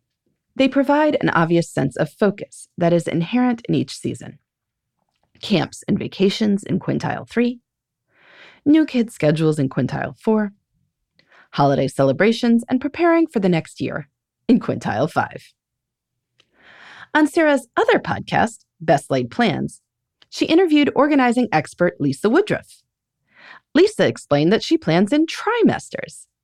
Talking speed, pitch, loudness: 125 wpm, 225 Hz, -19 LUFS